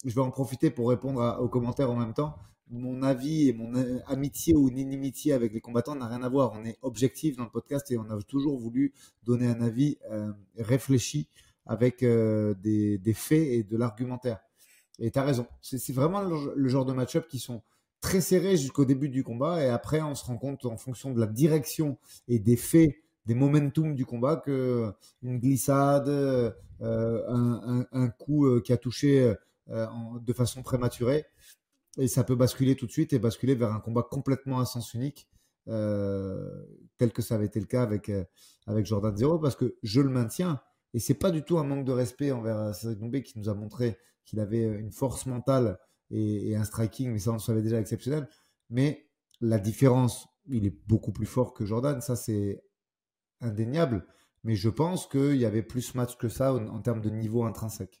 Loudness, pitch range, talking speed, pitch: -29 LUFS, 115-135 Hz, 205 wpm, 125 Hz